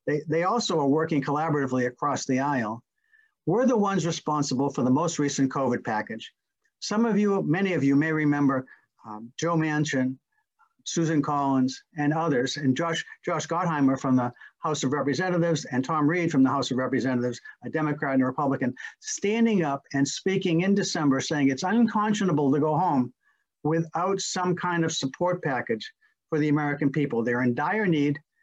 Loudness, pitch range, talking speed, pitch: -26 LUFS, 135-175 Hz, 175 wpm, 150 Hz